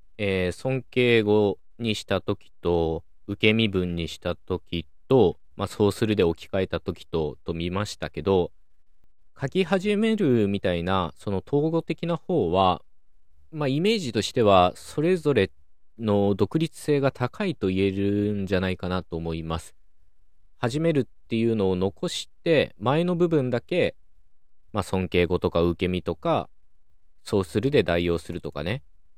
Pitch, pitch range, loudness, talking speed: 95 Hz, 85-120 Hz, -25 LUFS, 275 characters per minute